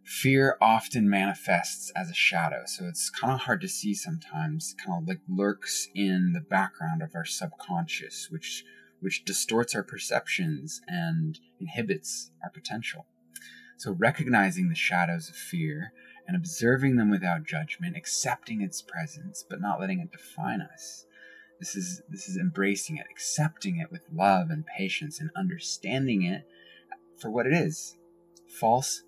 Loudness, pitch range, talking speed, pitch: -29 LUFS, 120-180 Hz, 150 wpm, 165 Hz